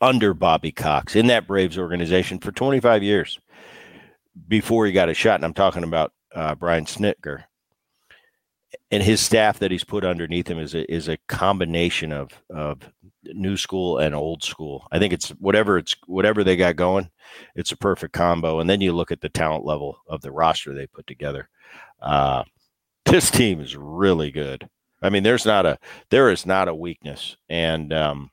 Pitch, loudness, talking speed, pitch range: 85 Hz, -21 LUFS, 185 wpm, 80-100 Hz